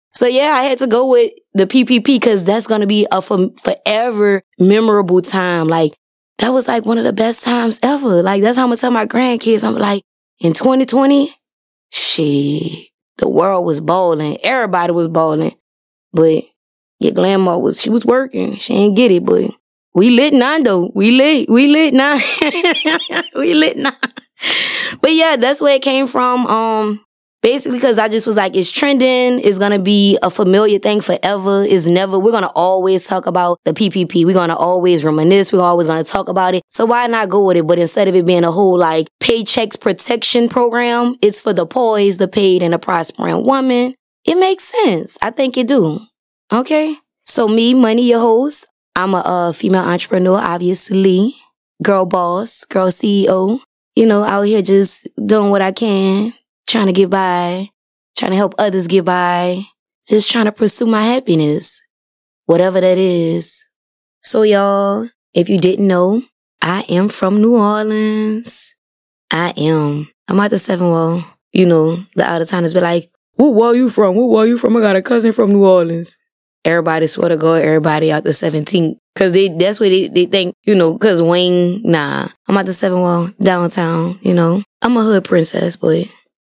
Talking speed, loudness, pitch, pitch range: 185 wpm, -13 LUFS, 200 Hz, 180-235 Hz